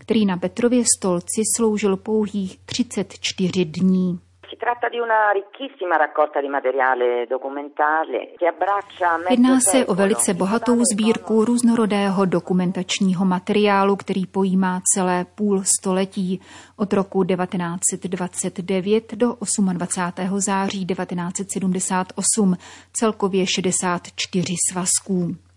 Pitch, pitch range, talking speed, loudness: 190 Hz, 180-210 Hz, 75 wpm, -20 LUFS